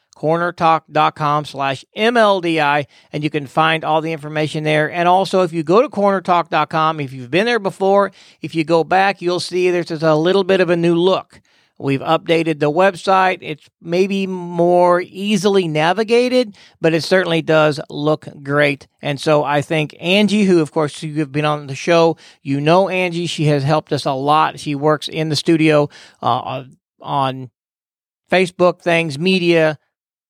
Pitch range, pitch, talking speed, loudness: 150-180 Hz, 165 Hz, 170 wpm, -16 LUFS